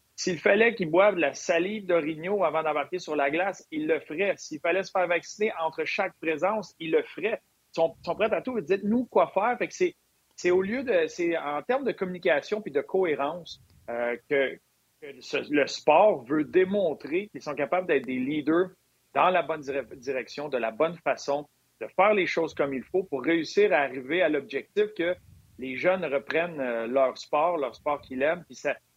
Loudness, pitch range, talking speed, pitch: -27 LUFS, 145-205 Hz, 210 wpm, 170 Hz